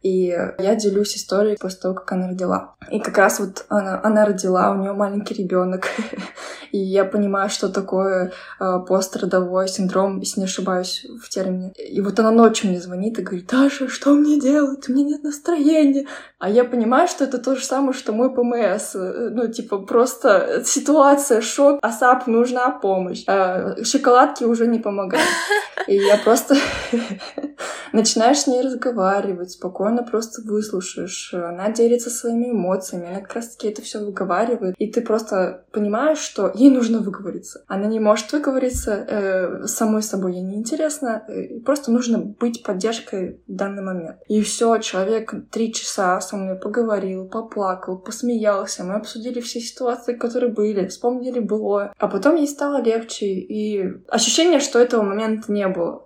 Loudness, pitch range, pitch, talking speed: -20 LUFS, 195-245 Hz, 215 Hz, 160 wpm